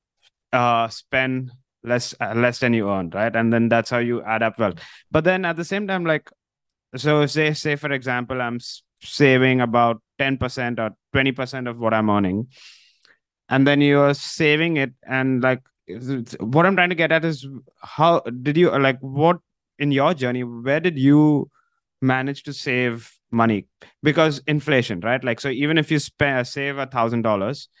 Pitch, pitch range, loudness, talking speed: 130 Hz, 120-145 Hz, -20 LUFS, 185 wpm